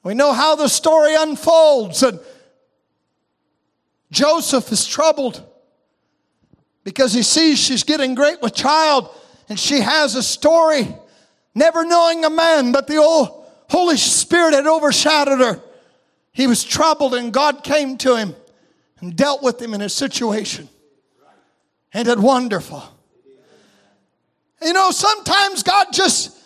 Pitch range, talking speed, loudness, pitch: 250-315 Hz, 130 wpm, -15 LUFS, 285 Hz